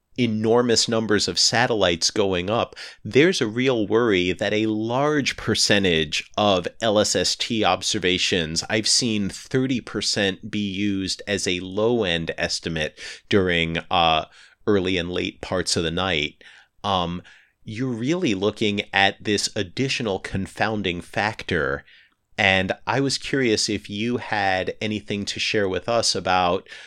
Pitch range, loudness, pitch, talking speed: 90-110 Hz, -22 LUFS, 105 Hz, 130 wpm